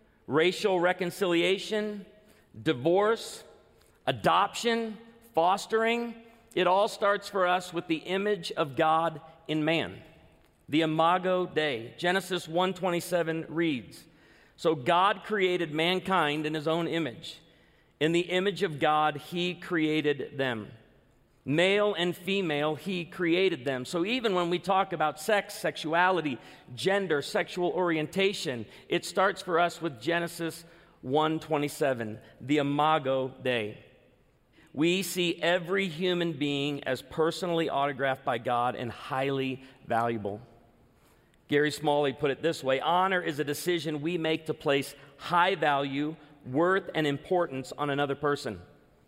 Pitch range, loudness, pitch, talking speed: 145-180 Hz, -28 LUFS, 165 Hz, 125 wpm